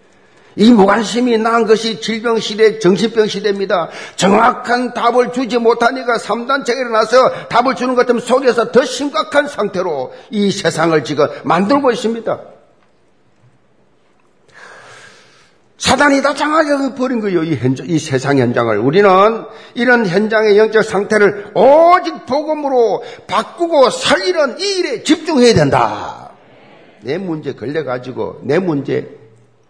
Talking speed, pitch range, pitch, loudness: 270 characters per minute, 200-255 Hz, 230 Hz, -13 LUFS